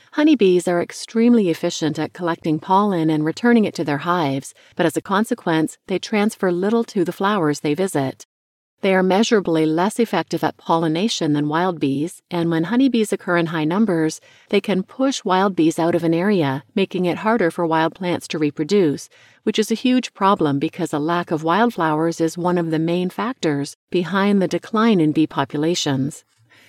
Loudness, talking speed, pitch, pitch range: -19 LUFS, 180 wpm, 175 Hz, 160-200 Hz